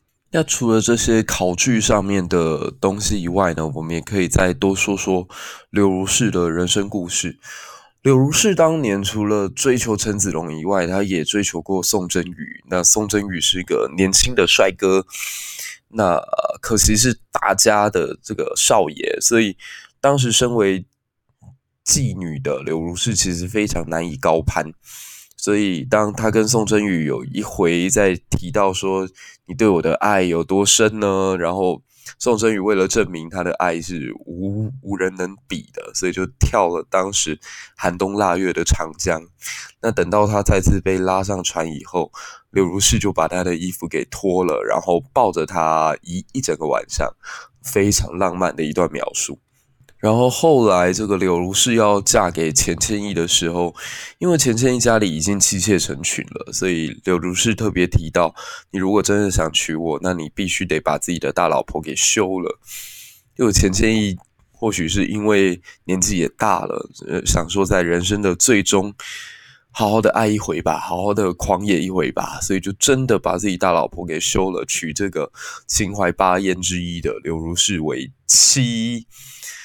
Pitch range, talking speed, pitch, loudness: 90-105 Hz, 250 characters per minute, 95 Hz, -18 LUFS